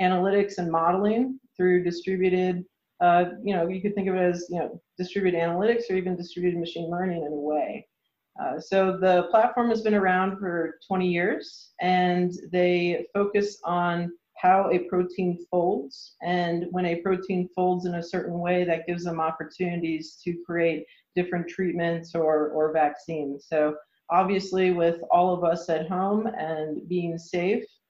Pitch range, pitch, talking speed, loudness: 170-185 Hz, 180 Hz, 155 wpm, -26 LUFS